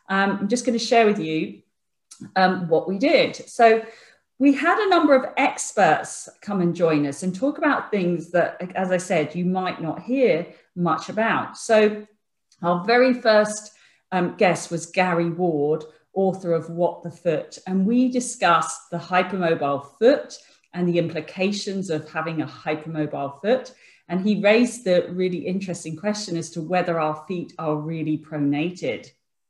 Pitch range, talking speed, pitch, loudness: 160-210 Hz, 165 wpm, 180 Hz, -22 LUFS